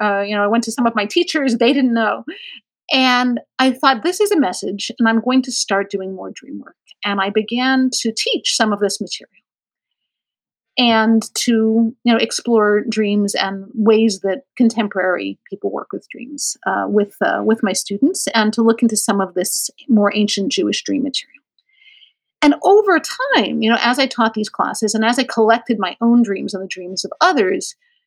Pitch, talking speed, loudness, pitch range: 230 Hz, 195 wpm, -17 LUFS, 205-265 Hz